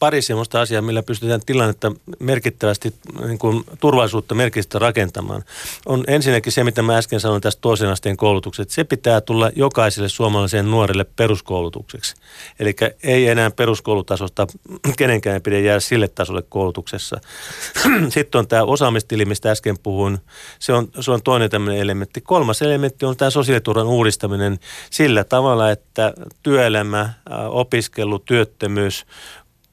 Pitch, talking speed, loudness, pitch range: 115 Hz, 135 wpm, -18 LUFS, 105-125 Hz